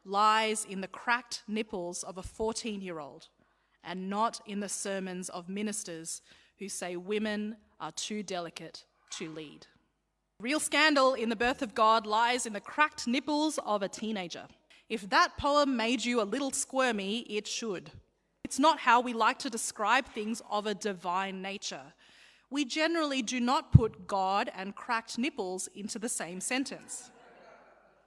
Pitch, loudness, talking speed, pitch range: 220 Hz, -31 LUFS, 160 wpm, 195-255 Hz